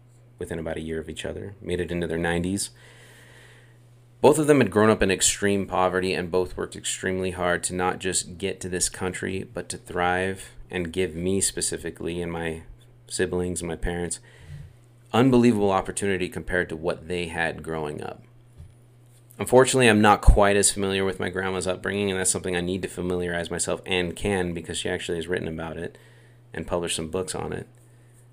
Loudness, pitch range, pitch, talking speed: -24 LUFS, 85-115 Hz, 95 Hz, 185 wpm